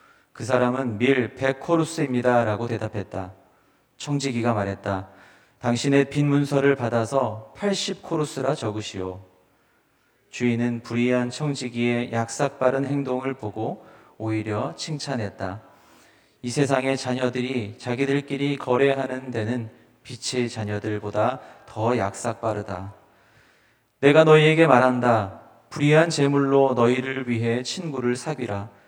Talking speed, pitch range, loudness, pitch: 260 characters per minute, 110-140 Hz, -23 LUFS, 125 Hz